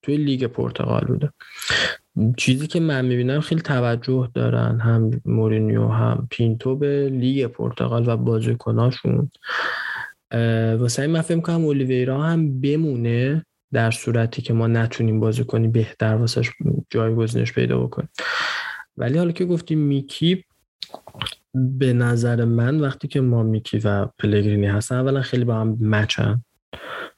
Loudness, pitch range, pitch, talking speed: -21 LUFS, 115-140 Hz, 120 Hz, 130 wpm